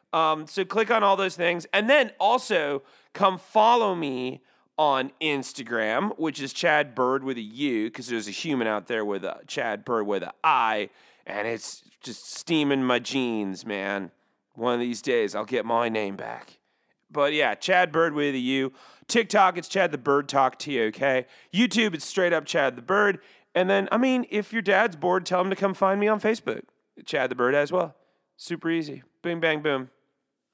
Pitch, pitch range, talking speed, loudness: 160 Hz, 130-195 Hz, 195 wpm, -25 LUFS